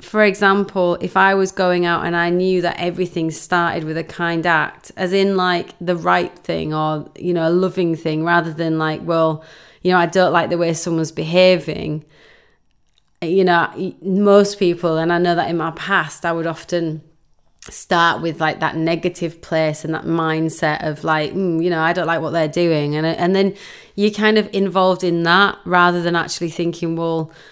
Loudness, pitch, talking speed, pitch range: -18 LUFS, 170 Hz, 195 wpm, 160-180 Hz